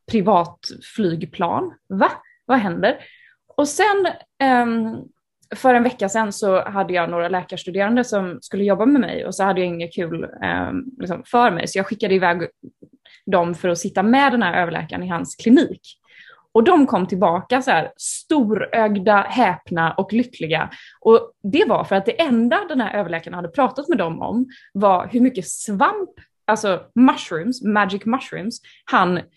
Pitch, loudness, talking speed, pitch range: 215 Hz, -19 LUFS, 160 wpm, 185-260 Hz